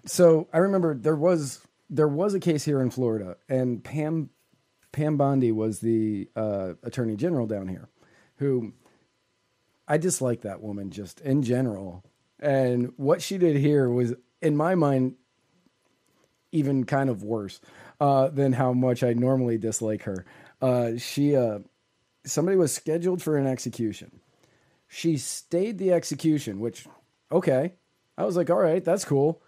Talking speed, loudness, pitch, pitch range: 150 wpm, -25 LUFS, 135 Hz, 120-155 Hz